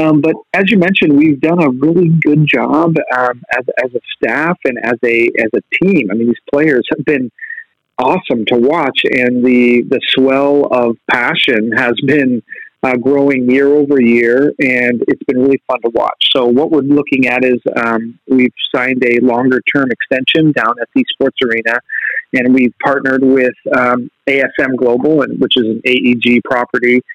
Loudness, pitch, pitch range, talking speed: -12 LUFS, 130 Hz, 125-145 Hz, 180 wpm